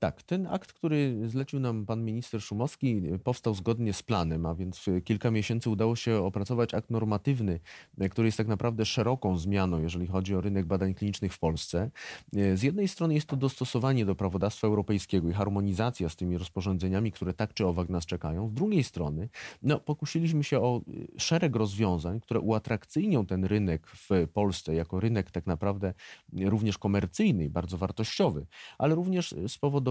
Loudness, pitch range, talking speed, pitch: -30 LUFS, 95-120 Hz, 170 wpm, 105 Hz